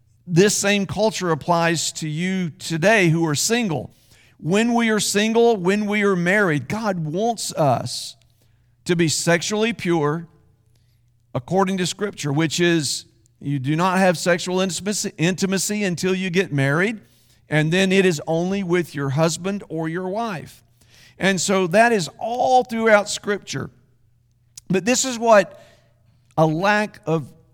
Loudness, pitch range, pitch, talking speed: -20 LUFS, 140-200 Hz, 170 Hz, 140 wpm